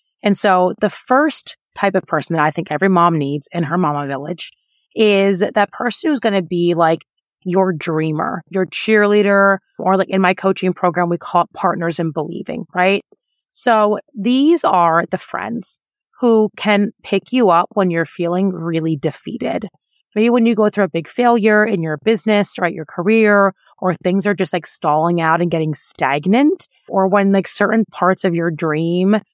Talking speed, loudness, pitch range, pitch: 180 wpm, -16 LUFS, 170-210 Hz, 190 Hz